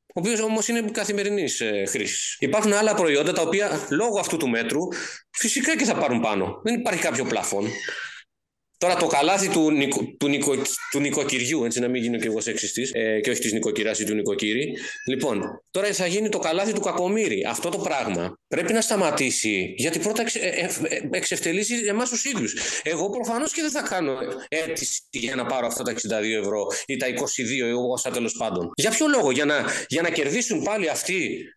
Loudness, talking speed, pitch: -24 LUFS, 200 wpm, 180 Hz